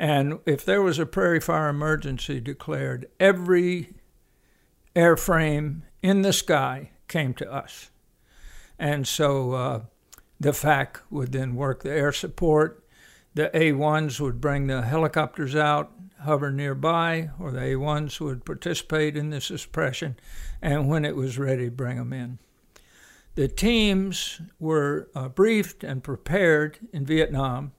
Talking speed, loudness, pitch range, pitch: 140 wpm, -25 LUFS, 135-165 Hz, 150 Hz